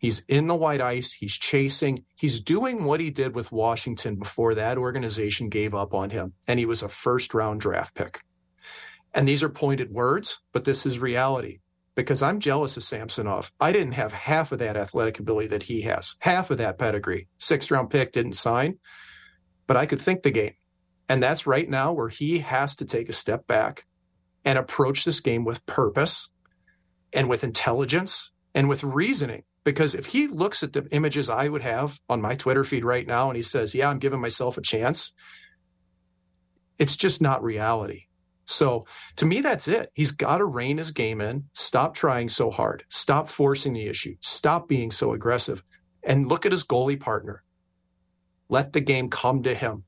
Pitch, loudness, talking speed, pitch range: 125 Hz, -25 LUFS, 190 wpm, 105-140 Hz